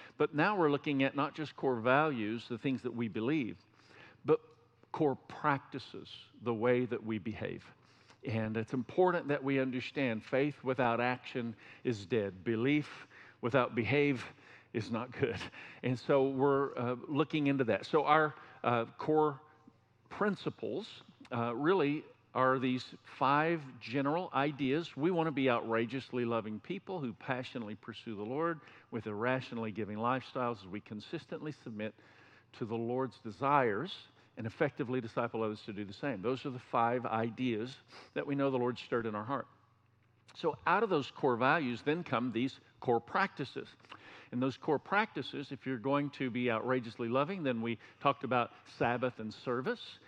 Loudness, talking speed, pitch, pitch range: -35 LUFS, 160 wpm, 125 Hz, 115-145 Hz